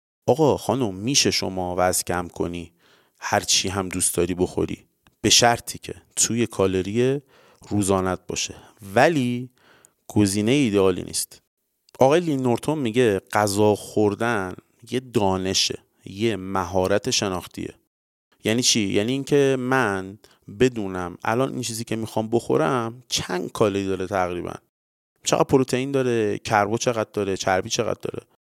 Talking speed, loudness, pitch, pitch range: 125 wpm, -22 LUFS, 105 Hz, 95-125 Hz